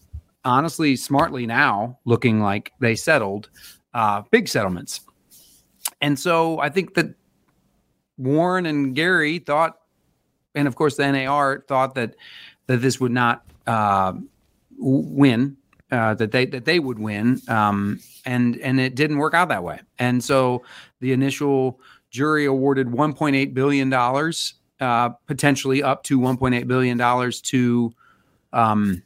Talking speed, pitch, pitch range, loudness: 145 wpm, 130 Hz, 120-145 Hz, -21 LUFS